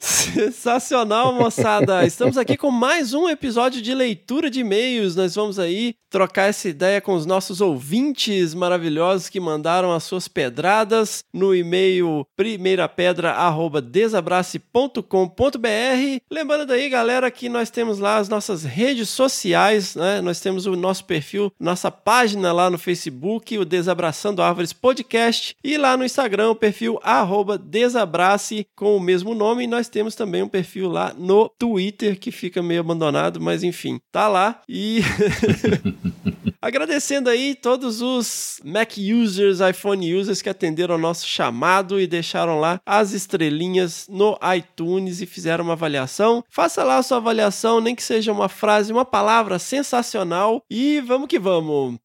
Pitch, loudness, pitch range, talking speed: 205 Hz, -20 LUFS, 180-235 Hz, 150 wpm